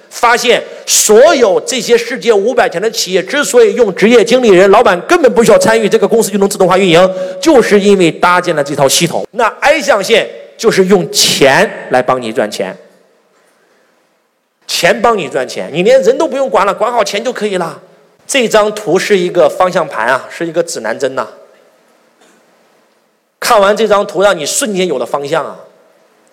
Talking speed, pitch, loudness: 270 characters per minute, 205 Hz, -10 LUFS